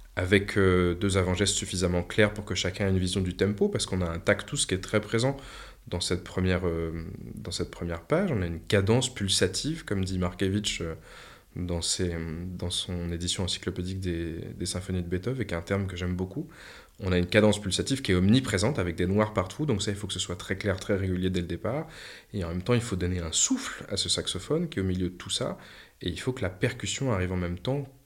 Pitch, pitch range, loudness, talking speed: 95 Hz, 90-105 Hz, -28 LUFS, 240 wpm